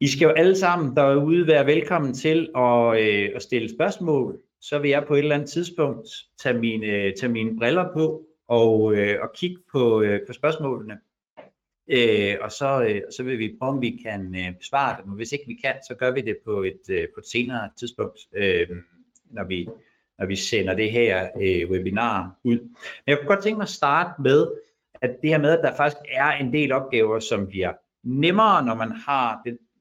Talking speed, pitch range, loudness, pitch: 205 wpm, 110-155 Hz, -23 LUFS, 130 Hz